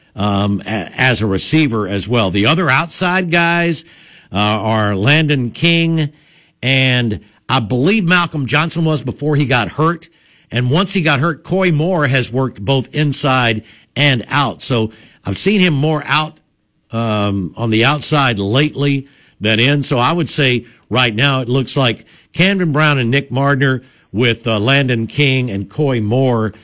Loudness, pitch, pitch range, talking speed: -14 LUFS, 135 Hz, 115-155 Hz, 160 wpm